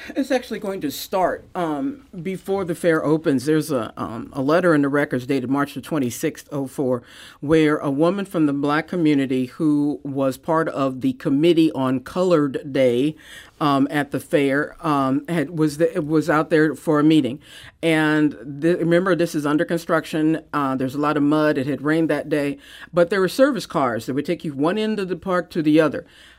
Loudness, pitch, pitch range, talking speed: -21 LUFS, 155 Hz, 140-170 Hz, 200 wpm